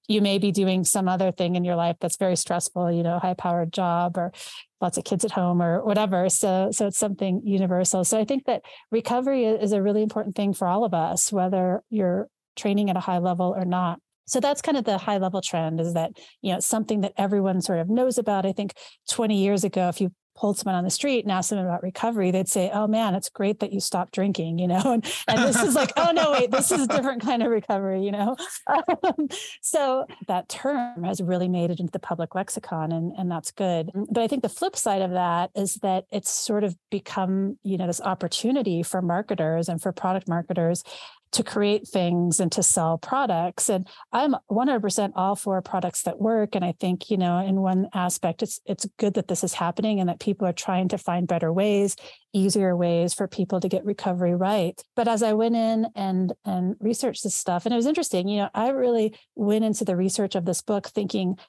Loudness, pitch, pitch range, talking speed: -24 LUFS, 195 Hz, 180-220 Hz, 225 wpm